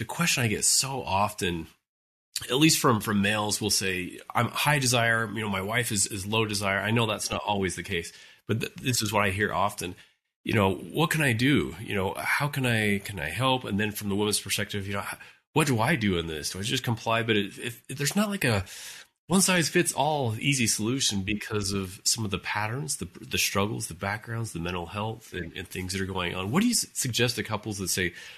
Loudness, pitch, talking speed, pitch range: -26 LUFS, 105 Hz, 240 wpm, 95-120 Hz